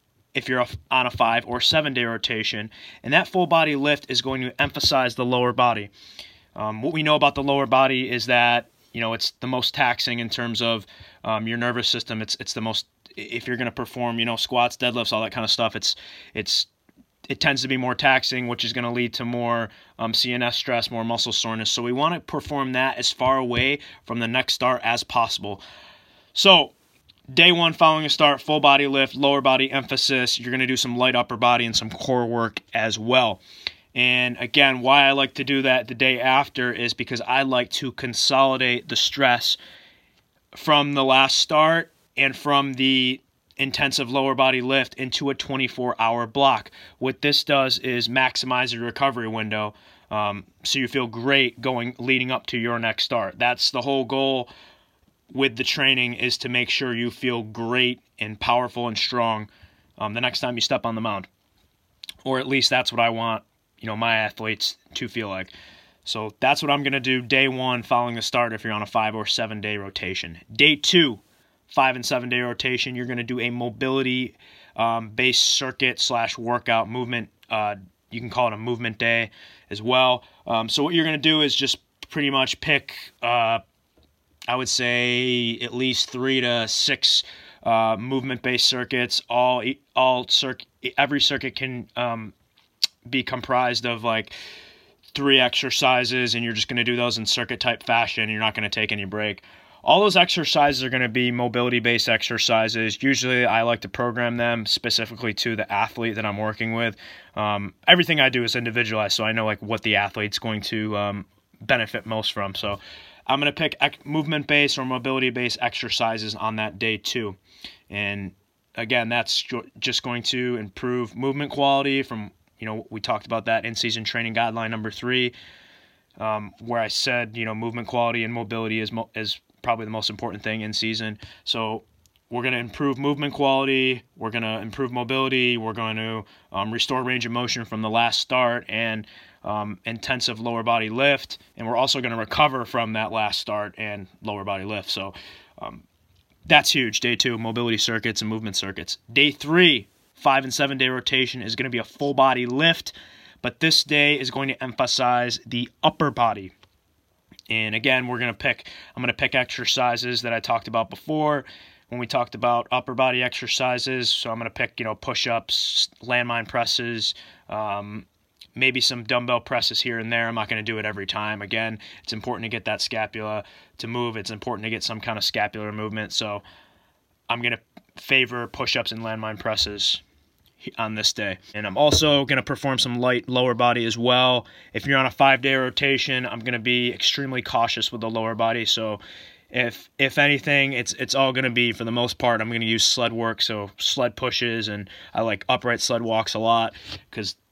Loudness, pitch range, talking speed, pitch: -22 LUFS, 110-130 Hz, 195 wpm, 120 Hz